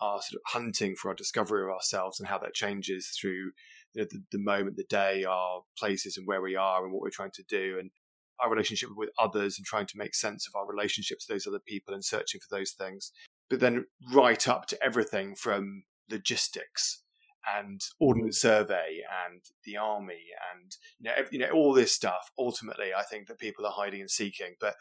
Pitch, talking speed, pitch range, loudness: 100 Hz, 215 wpm, 95-125 Hz, -31 LUFS